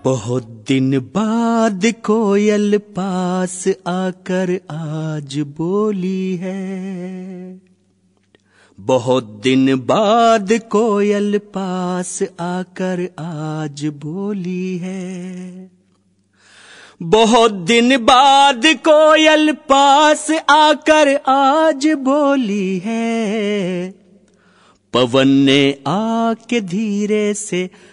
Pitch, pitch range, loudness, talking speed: 190 Hz, 175-225 Hz, -15 LUFS, 70 wpm